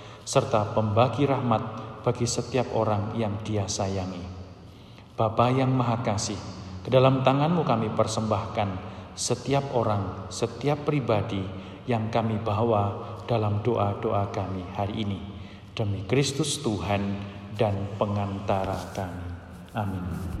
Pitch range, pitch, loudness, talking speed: 100-115 Hz, 105 Hz, -27 LUFS, 110 wpm